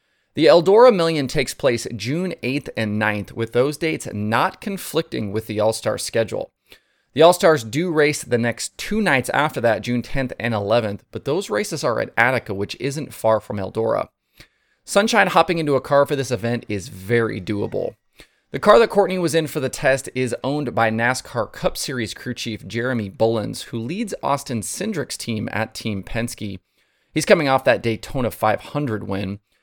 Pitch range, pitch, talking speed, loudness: 110-145 Hz, 120 Hz, 180 wpm, -20 LUFS